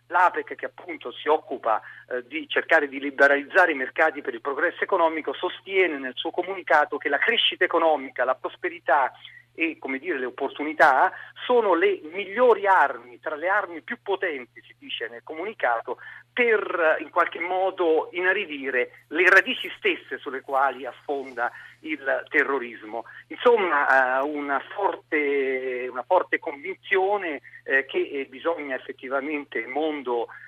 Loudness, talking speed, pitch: -24 LUFS, 135 wpm, 160 Hz